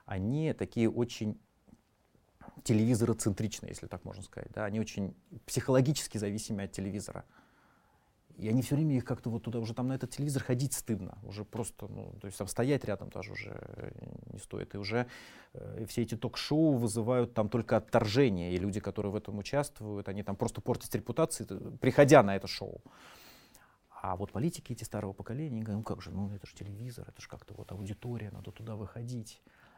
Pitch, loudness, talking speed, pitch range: 115 Hz, -33 LUFS, 180 wpm, 105-125 Hz